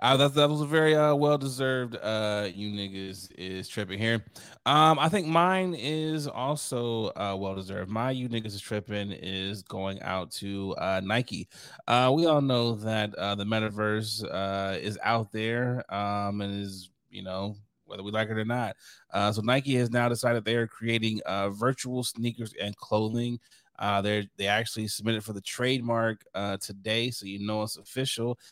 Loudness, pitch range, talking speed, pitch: -28 LUFS, 100-125 Hz, 180 wpm, 110 Hz